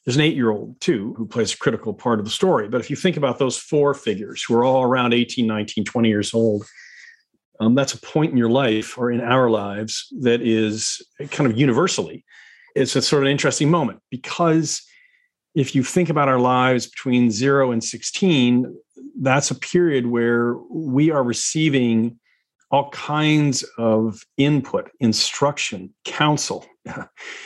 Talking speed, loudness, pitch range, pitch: 165 wpm, -20 LUFS, 115-145 Hz, 130 Hz